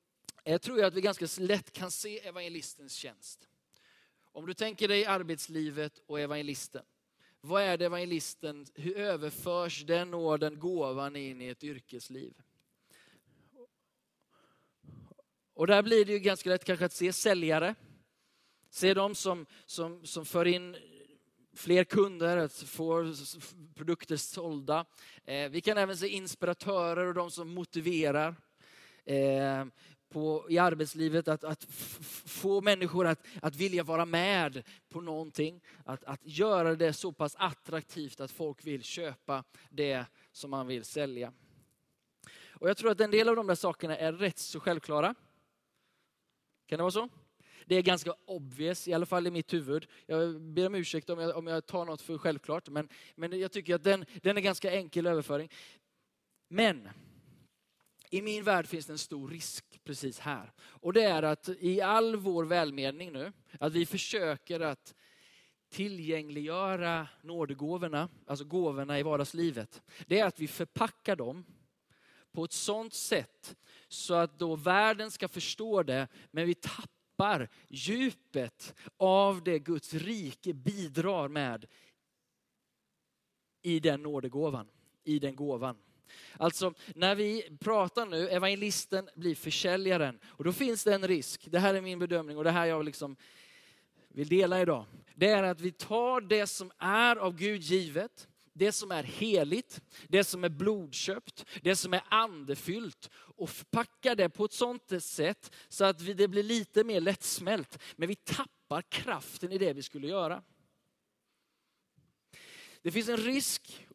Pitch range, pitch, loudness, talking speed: 150-190 Hz, 170 Hz, -32 LUFS, 150 wpm